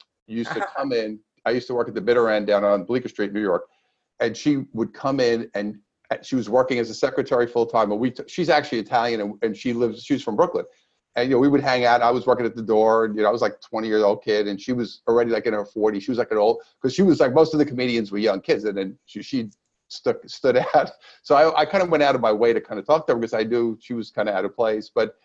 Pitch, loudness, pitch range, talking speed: 115 Hz, -22 LUFS, 110-130 Hz, 300 wpm